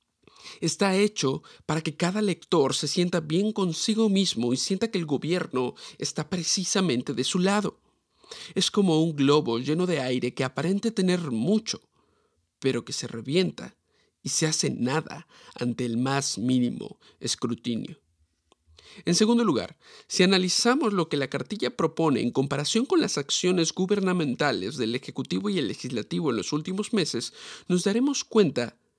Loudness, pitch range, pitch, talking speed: -26 LUFS, 135-195 Hz, 170 Hz, 150 wpm